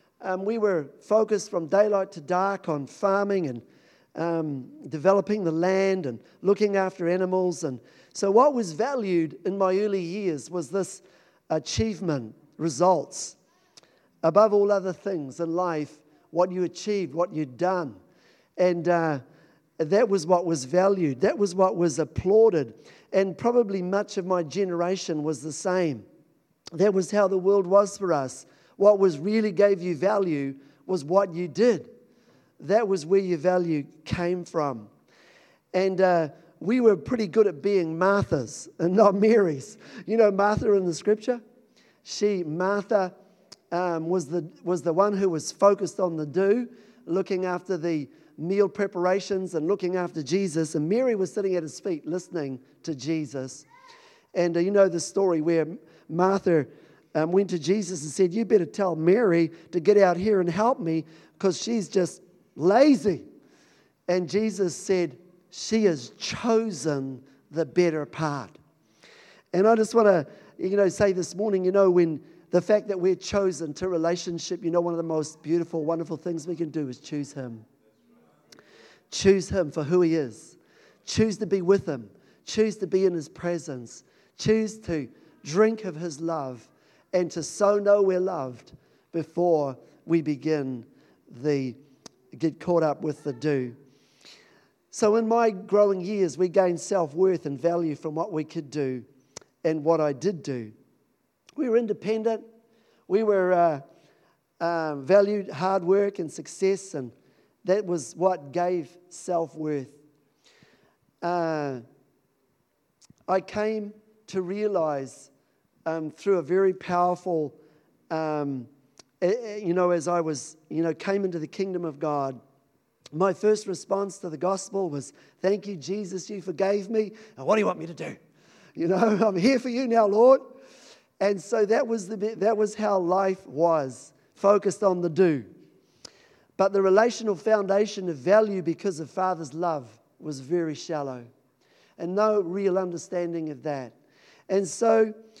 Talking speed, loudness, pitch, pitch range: 155 wpm, -25 LUFS, 180 Hz, 160-200 Hz